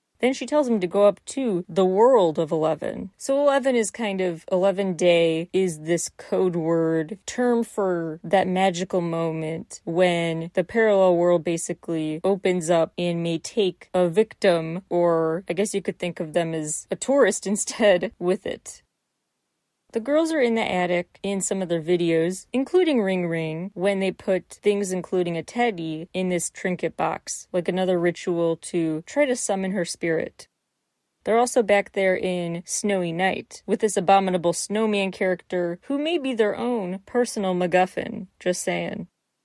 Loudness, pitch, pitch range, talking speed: -23 LUFS, 185 Hz, 170-205 Hz, 165 wpm